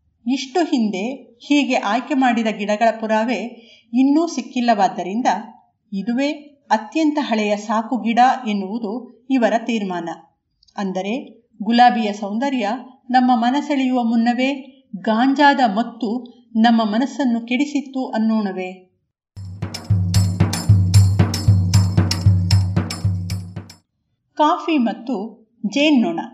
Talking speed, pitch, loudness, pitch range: 75 wpm, 230 Hz, -19 LUFS, 190-255 Hz